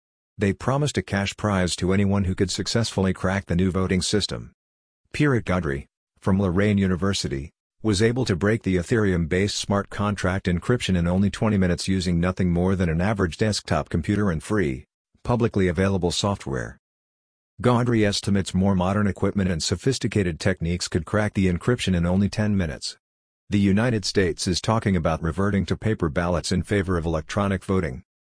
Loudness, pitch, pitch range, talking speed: -23 LUFS, 95 Hz, 90-105 Hz, 165 wpm